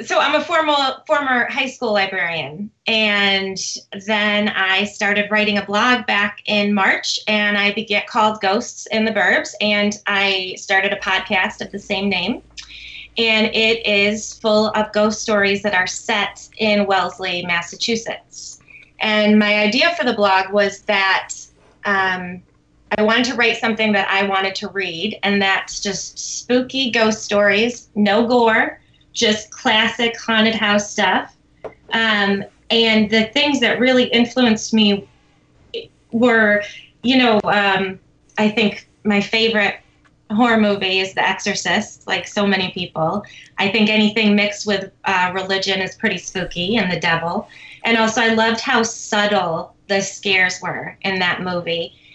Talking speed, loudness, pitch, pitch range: 150 wpm, -17 LUFS, 205 Hz, 195-225 Hz